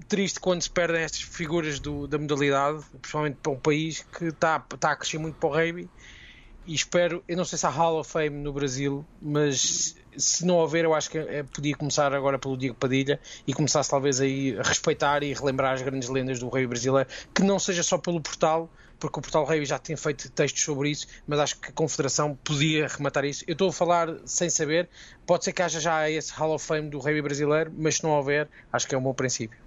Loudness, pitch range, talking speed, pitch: -26 LUFS, 140-165 Hz, 235 wpm, 150 Hz